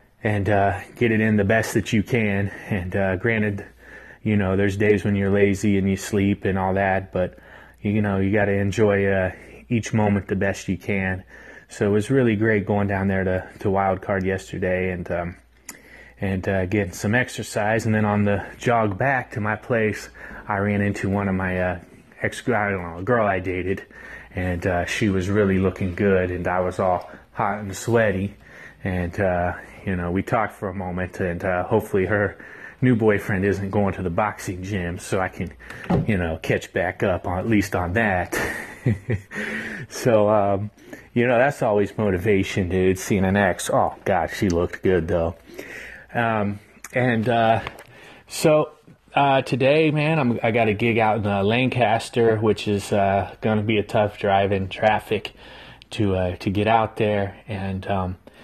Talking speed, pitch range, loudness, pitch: 185 wpm, 95-110 Hz, -22 LUFS, 100 Hz